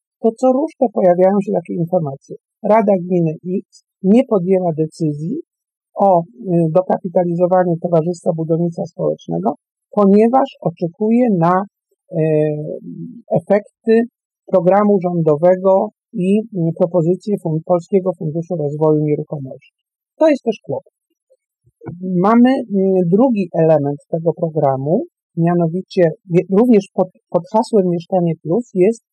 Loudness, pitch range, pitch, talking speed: -16 LUFS, 170-210 Hz, 185 Hz, 95 wpm